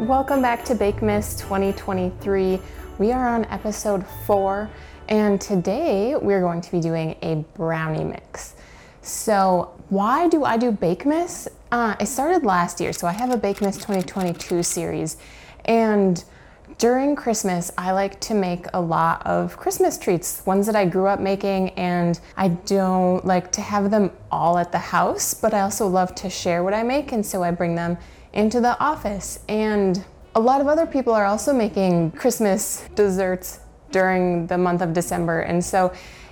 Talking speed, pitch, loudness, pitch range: 175 wpm, 195 Hz, -21 LUFS, 180-220 Hz